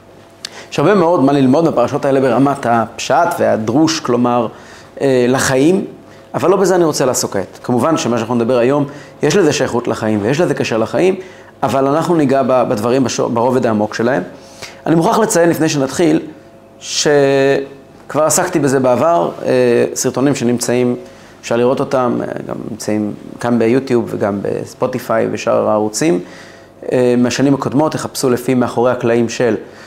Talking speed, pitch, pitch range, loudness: 135 wpm, 130 Hz, 120-145 Hz, -14 LUFS